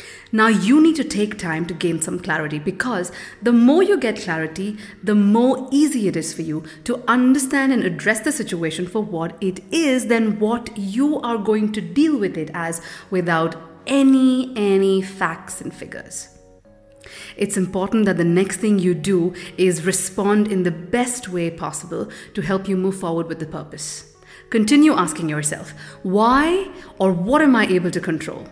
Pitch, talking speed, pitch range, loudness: 195 Hz, 175 wpm, 170-235 Hz, -19 LUFS